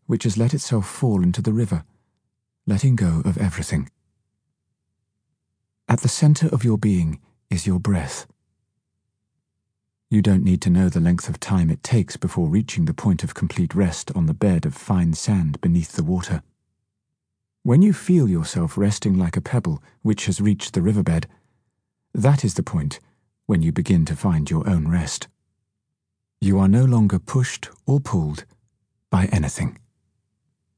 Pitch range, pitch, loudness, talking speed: 90-125 Hz, 100 Hz, -21 LUFS, 160 wpm